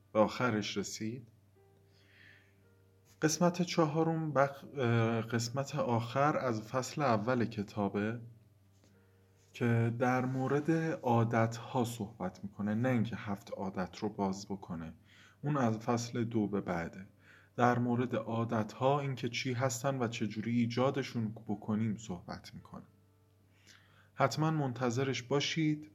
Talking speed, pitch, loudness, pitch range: 110 wpm, 115 Hz, -34 LUFS, 100-130 Hz